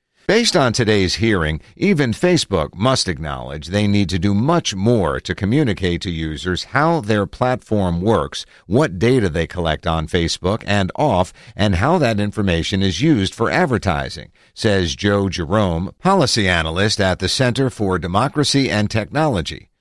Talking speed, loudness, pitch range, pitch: 150 wpm, -18 LUFS, 90-125 Hz, 100 Hz